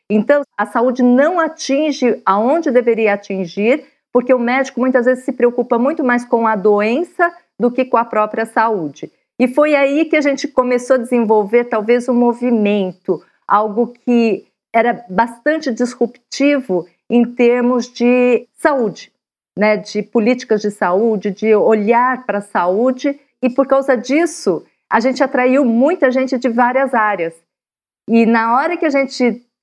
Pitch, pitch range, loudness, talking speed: 245 Hz, 225-265 Hz, -15 LUFS, 150 wpm